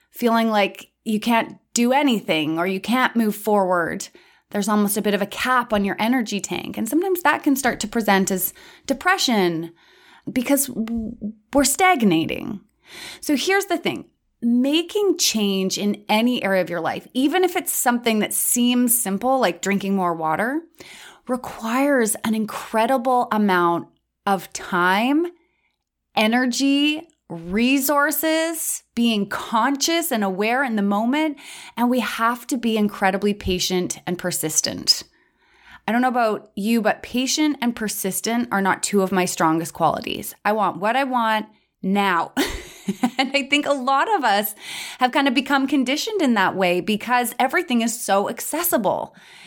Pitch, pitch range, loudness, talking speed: 230 Hz, 200-275 Hz, -21 LUFS, 150 wpm